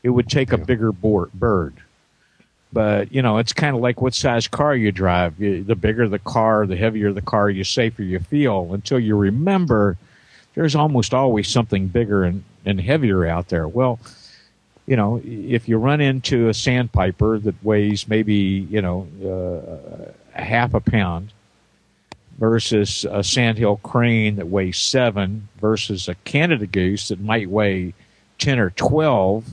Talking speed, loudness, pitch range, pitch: 165 wpm, -19 LUFS, 100-120 Hz, 110 Hz